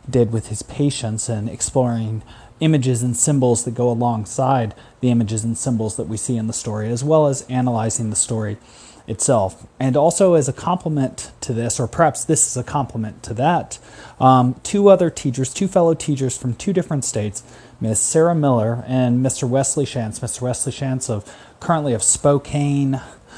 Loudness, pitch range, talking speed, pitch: -19 LUFS, 115-140 Hz, 175 wpm, 125 Hz